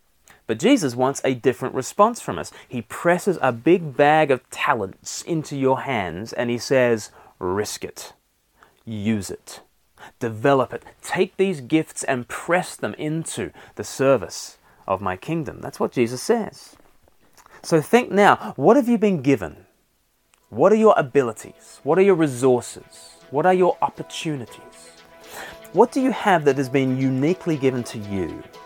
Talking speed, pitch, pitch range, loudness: 155 wpm, 135 Hz, 120-170 Hz, -21 LUFS